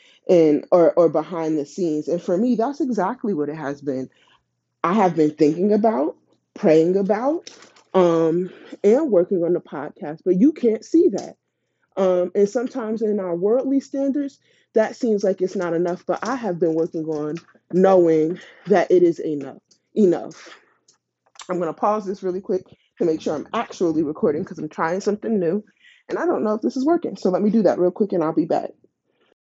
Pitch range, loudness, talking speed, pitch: 170-245 Hz, -21 LUFS, 195 wpm, 190 Hz